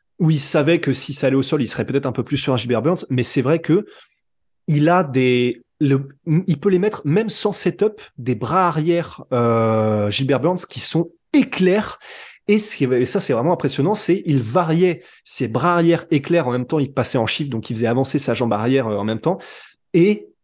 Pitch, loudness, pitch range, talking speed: 150 Hz, -19 LUFS, 125-175 Hz, 220 wpm